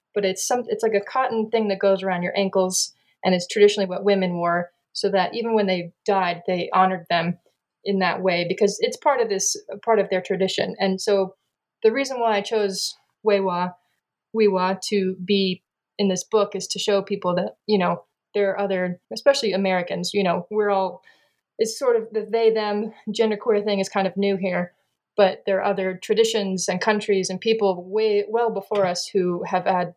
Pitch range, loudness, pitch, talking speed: 185-215 Hz, -22 LUFS, 195 Hz, 200 wpm